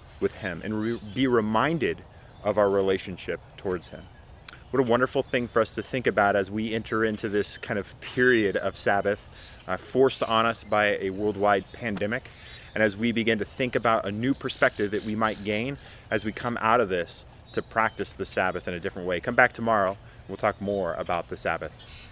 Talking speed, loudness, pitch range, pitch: 205 wpm, -26 LUFS, 100-120 Hz, 110 Hz